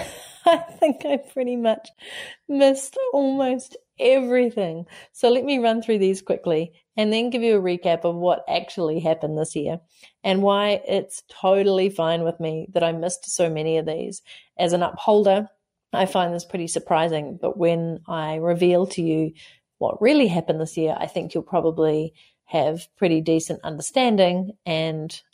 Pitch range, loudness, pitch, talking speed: 165-230 Hz, -22 LUFS, 180 Hz, 165 wpm